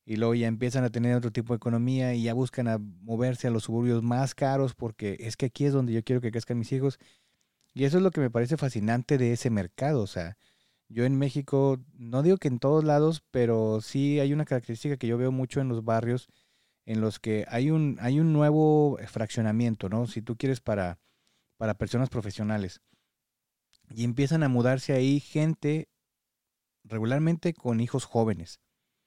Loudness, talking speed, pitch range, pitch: -28 LUFS, 190 wpm, 115-140 Hz, 125 Hz